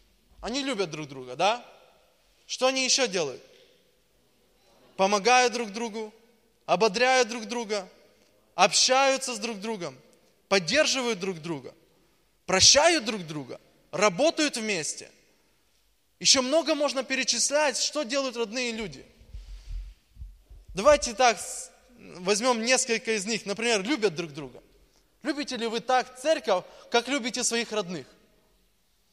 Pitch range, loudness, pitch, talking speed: 205-265 Hz, -25 LUFS, 235 Hz, 110 wpm